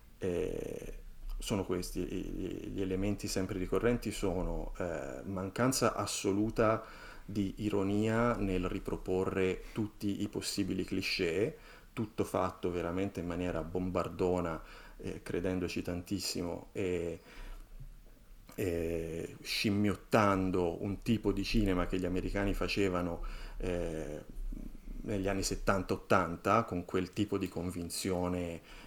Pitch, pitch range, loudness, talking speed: 95 Hz, 90-105 Hz, -35 LUFS, 100 wpm